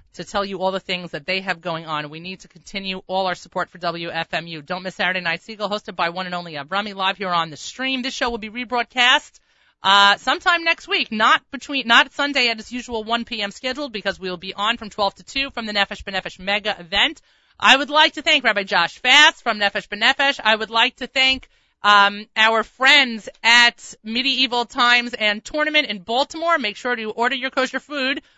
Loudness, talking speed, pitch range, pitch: -19 LUFS, 220 wpm, 190-260 Hz, 220 Hz